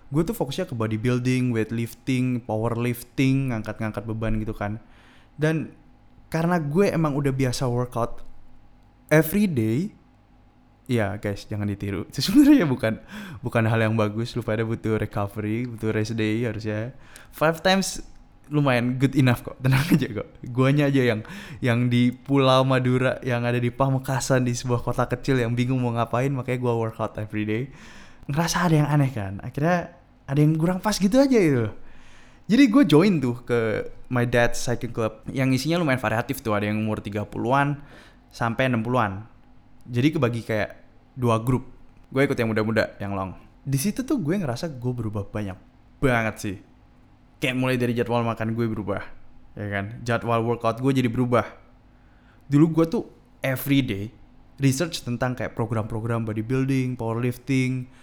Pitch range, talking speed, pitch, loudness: 110-135 Hz, 155 wpm, 120 Hz, -24 LUFS